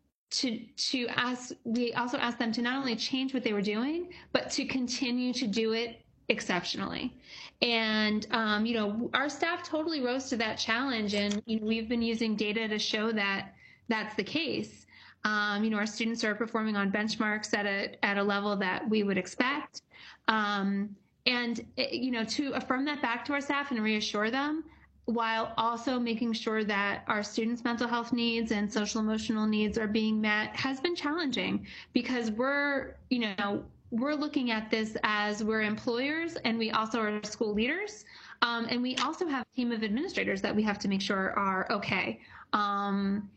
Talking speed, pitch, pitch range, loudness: 185 wpm, 230 Hz, 215-255 Hz, -31 LUFS